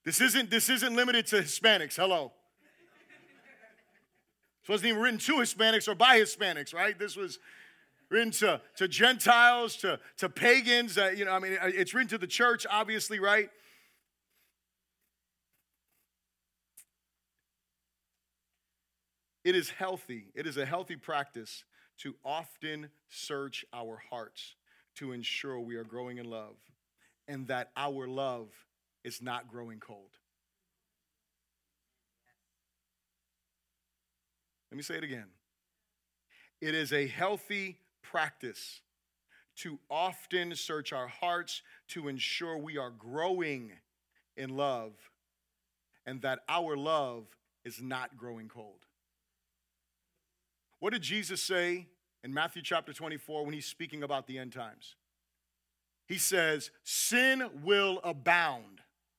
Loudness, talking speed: -30 LUFS, 120 wpm